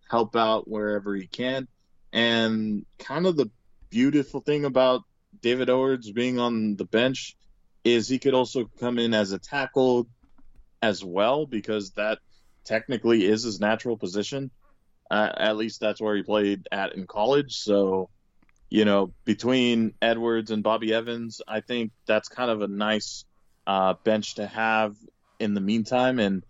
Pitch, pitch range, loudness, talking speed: 110 Hz, 105-120 Hz, -25 LUFS, 155 wpm